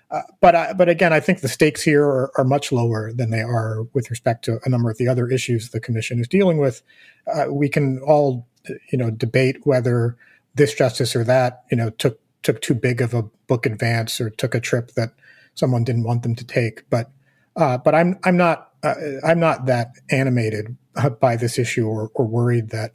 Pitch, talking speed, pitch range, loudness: 125 Hz, 215 wpm, 115-140 Hz, -20 LUFS